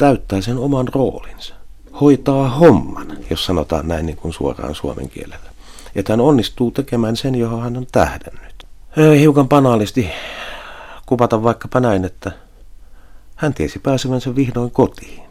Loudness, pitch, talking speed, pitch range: -16 LUFS, 120 Hz, 135 wpm, 95-130 Hz